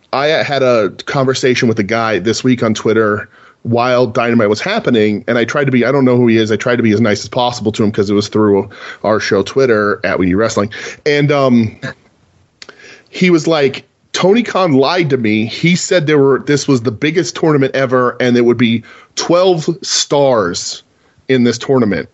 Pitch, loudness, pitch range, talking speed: 125 Hz, -13 LUFS, 115-140 Hz, 205 wpm